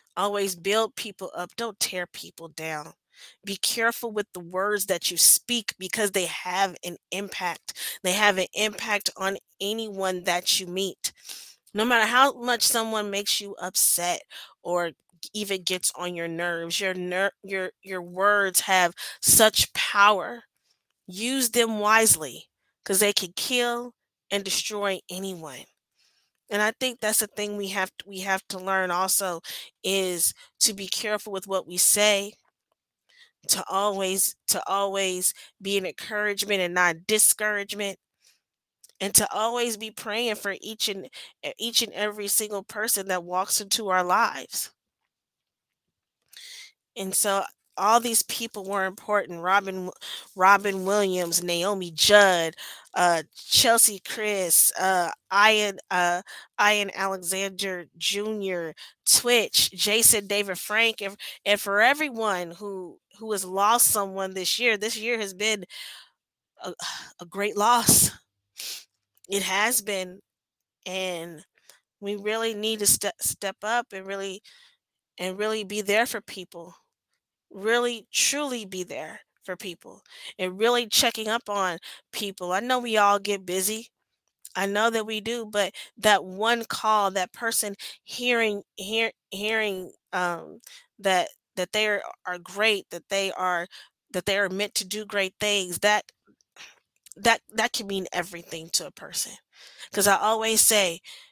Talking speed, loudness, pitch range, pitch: 140 wpm, -24 LUFS, 185-215 Hz, 200 Hz